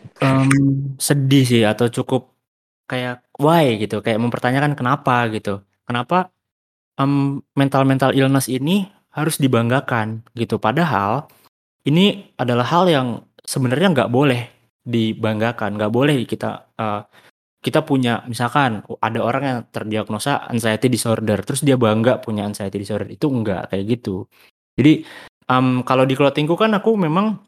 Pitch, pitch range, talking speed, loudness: 125 Hz, 110-140 Hz, 135 wpm, -18 LUFS